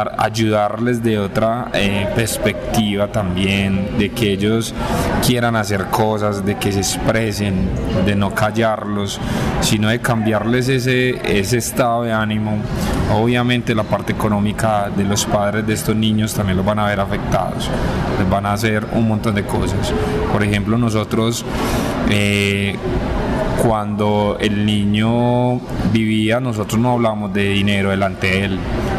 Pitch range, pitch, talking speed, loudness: 100-115 Hz, 105 Hz, 140 wpm, -17 LUFS